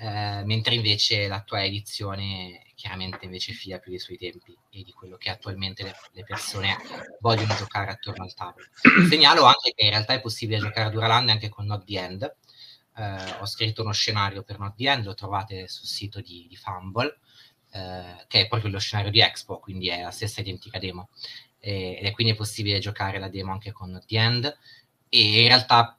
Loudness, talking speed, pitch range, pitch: -22 LUFS, 200 wpm, 95-115 Hz, 105 Hz